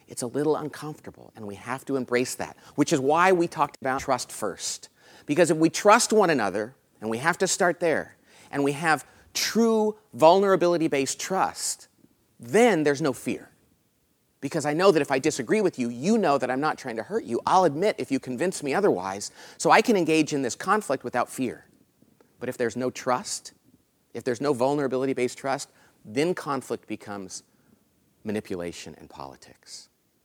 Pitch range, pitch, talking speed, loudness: 125-165 Hz, 140 Hz, 185 wpm, -25 LUFS